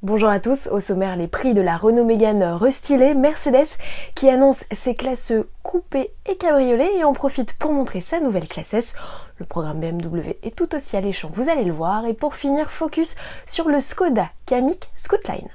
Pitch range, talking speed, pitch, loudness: 200-290 Hz, 190 wpm, 255 Hz, -20 LUFS